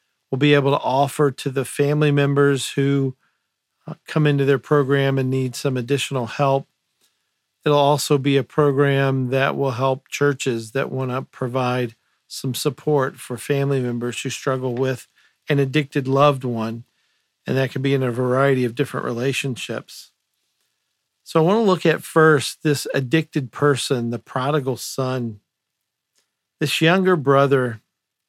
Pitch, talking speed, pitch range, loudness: 135 Hz, 150 wpm, 130-145 Hz, -20 LUFS